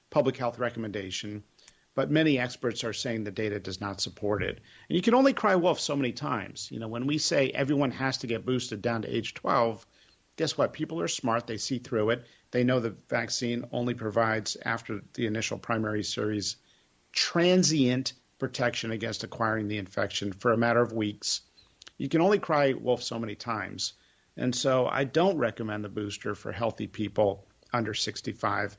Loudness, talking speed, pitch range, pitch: -29 LUFS, 185 wpm, 105-130 Hz, 115 Hz